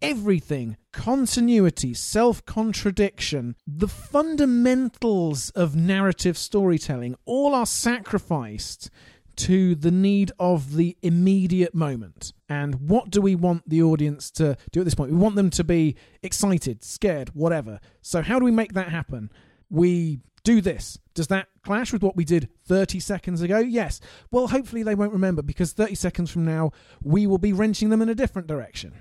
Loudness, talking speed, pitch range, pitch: -23 LUFS, 165 wpm, 155-210 Hz, 180 Hz